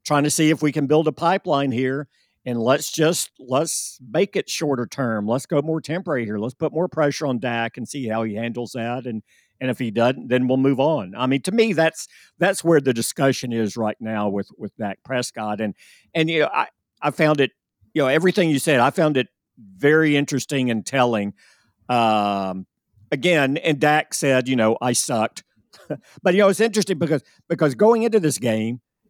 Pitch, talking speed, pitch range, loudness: 135 Hz, 205 wpm, 120-160 Hz, -21 LUFS